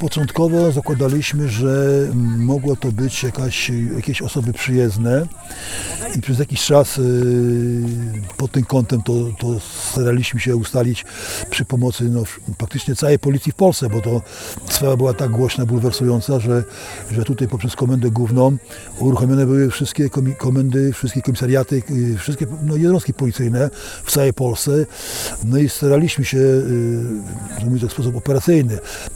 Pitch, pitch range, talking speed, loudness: 130 Hz, 120-135 Hz, 135 wpm, -18 LUFS